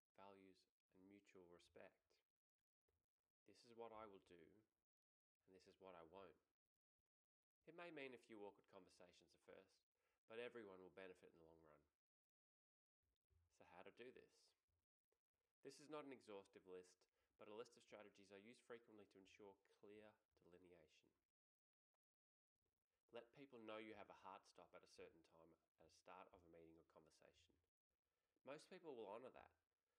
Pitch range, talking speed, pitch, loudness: 85-105 Hz, 160 wpm, 95 Hz, -63 LUFS